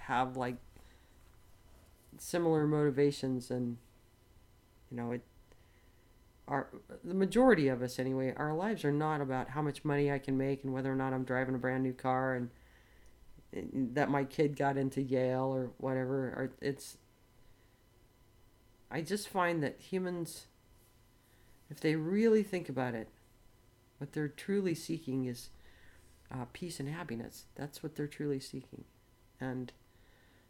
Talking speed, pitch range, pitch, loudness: 145 wpm, 115-145 Hz, 130 Hz, -35 LUFS